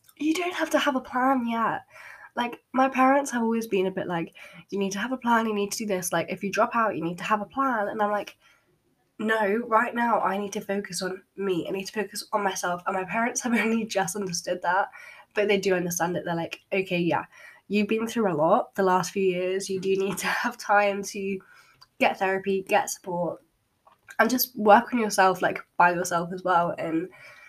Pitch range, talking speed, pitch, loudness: 190-230 Hz, 230 wpm, 200 Hz, -26 LUFS